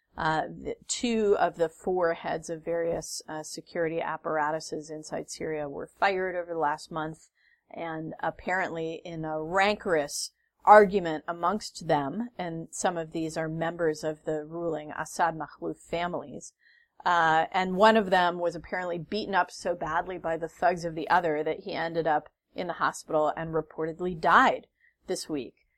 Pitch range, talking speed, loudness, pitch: 160-185 Hz, 155 wpm, -28 LUFS, 165 Hz